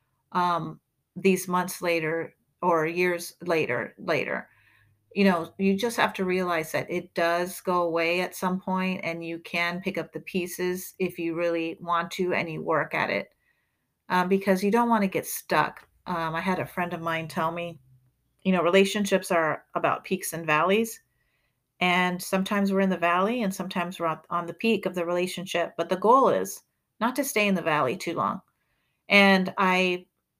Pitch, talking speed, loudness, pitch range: 175 Hz, 185 wpm, -26 LUFS, 165-185 Hz